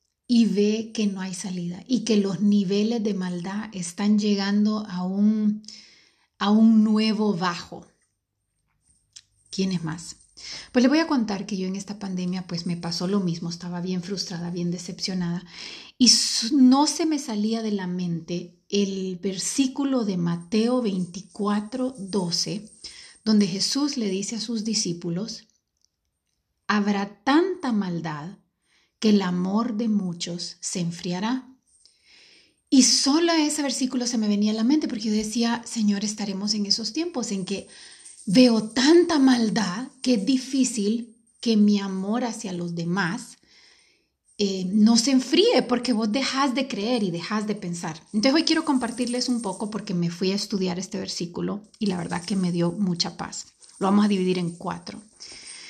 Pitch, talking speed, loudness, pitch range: 210 Hz, 155 wpm, -24 LUFS, 185-235 Hz